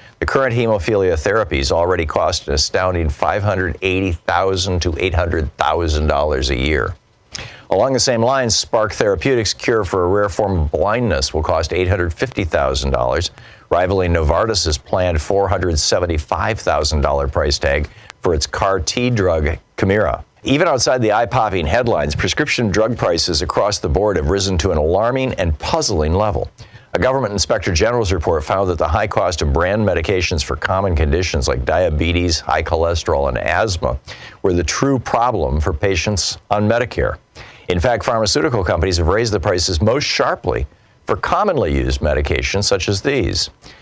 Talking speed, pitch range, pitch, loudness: 150 wpm, 80-100 Hz, 90 Hz, -17 LUFS